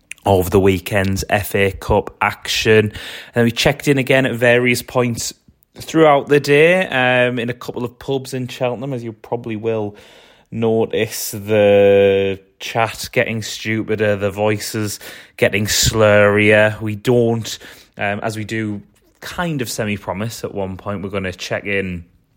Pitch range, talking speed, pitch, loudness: 100-125 Hz, 150 wpm, 110 Hz, -17 LUFS